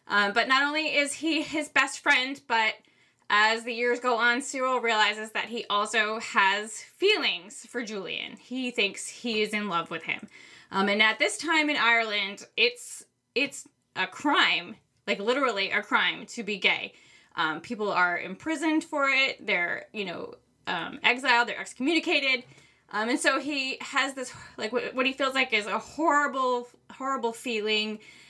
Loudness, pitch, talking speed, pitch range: -26 LUFS, 240 Hz, 170 wpm, 215-280 Hz